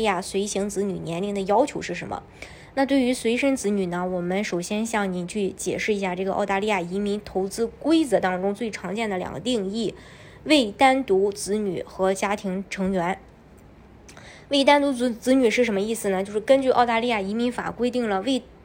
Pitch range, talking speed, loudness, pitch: 195-245 Hz, 295 characters per minute, -24 LUFS, 205 Hz